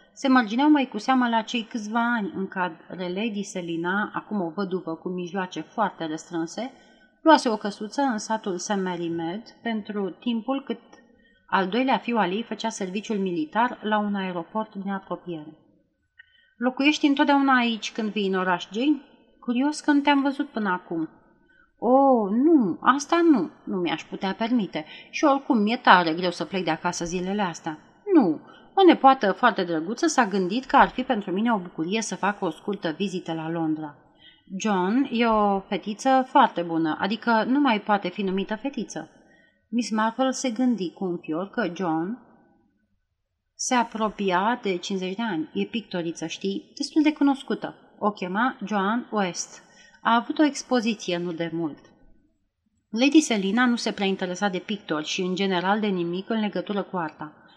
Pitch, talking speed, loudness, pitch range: 210 Hz, 165 wpm, -24 LUFS, 180-245 Hz